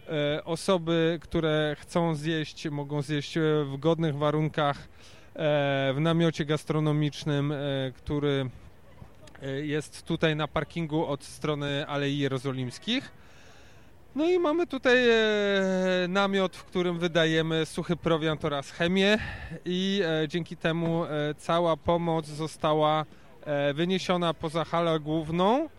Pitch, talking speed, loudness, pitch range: 160 Hz, 100 wpm, -28 LUFS, 145-170 Hz